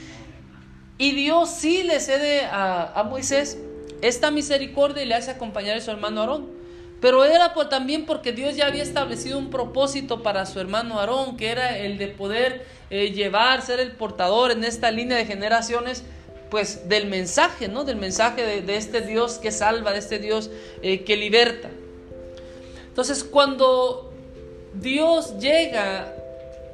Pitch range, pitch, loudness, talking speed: 205-280 Hz, 235 Hz, -22 LUFS, 155 wpm